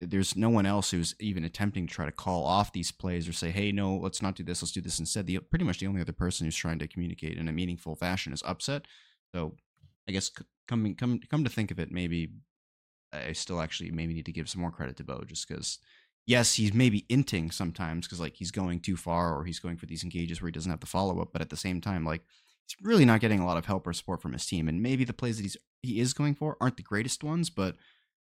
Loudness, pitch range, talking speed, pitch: -31 LUFS, 85-105 Hz, 270 wpm, 90 Hz